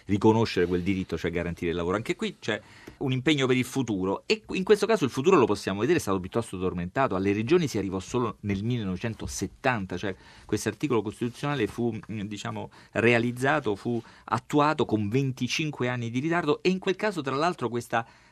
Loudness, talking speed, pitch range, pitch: -27 LUFS, 185 wpm, 100-135 Hz, 115 Hz